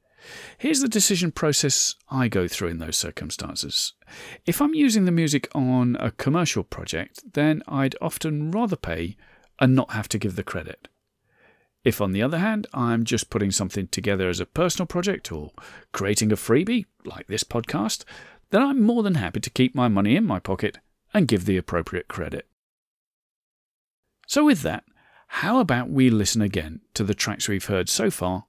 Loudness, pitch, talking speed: -23 LUFS, 125 Hz, 175 wpm